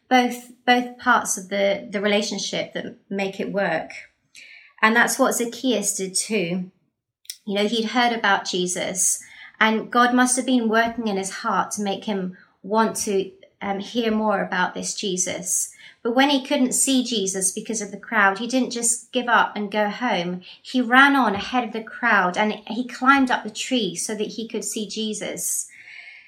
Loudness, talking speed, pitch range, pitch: -21 LUFS, 185 wpm, 200-240 Hz, 215 Hz